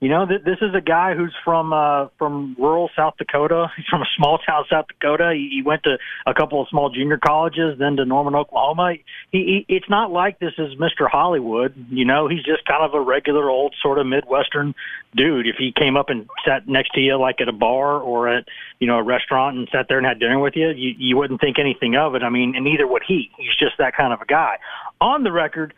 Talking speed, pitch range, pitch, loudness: 245 wpm, 135-165 Hz, 145 Hz, -19 LUFS